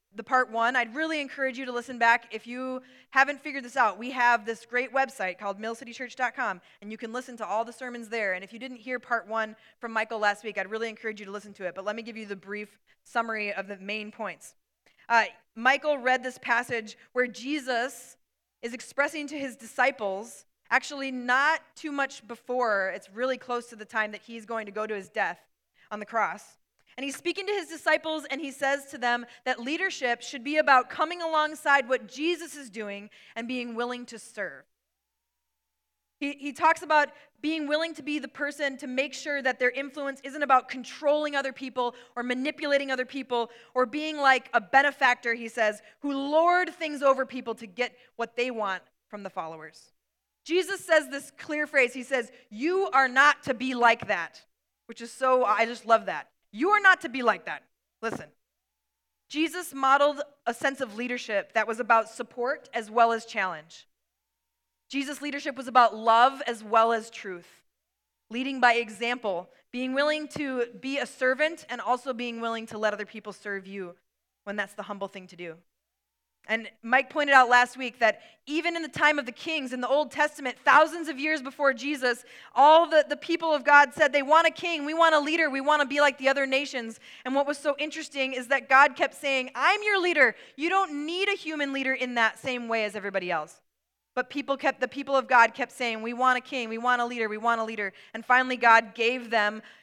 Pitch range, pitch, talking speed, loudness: 230-285 Hz, 255 Hz, 205 wpm, -26 LUFS